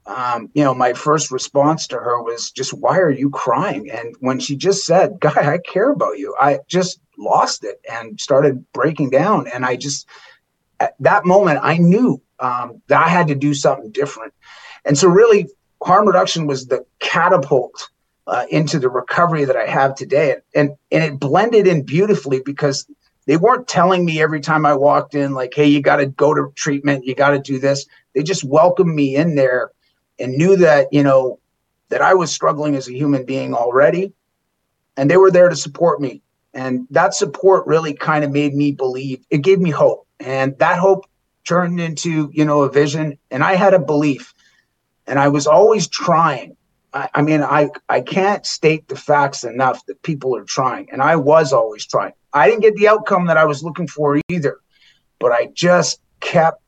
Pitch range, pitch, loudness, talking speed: 135-175 Hz, 150 Hz, -16 LUFS, 200 wpm